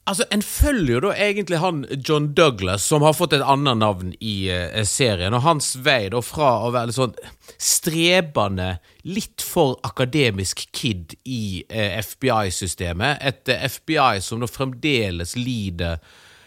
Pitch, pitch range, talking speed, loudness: 120 Hz, 100-145 Hz, 155 wpm, -21 LUFS